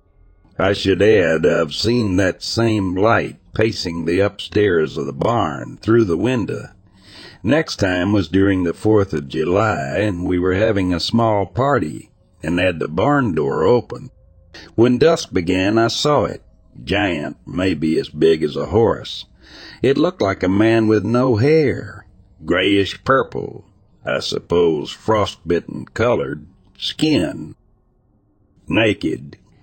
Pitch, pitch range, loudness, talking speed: 100 Hz, 90-110 Hz, -18 LUFS, 135 wpm